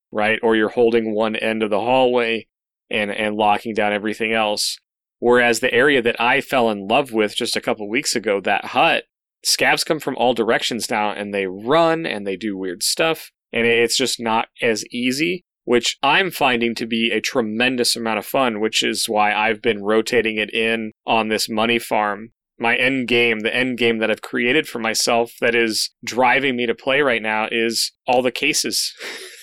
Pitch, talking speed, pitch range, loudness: 115 Hz, 200 wpm, 110-120 Hz, -19 LUFS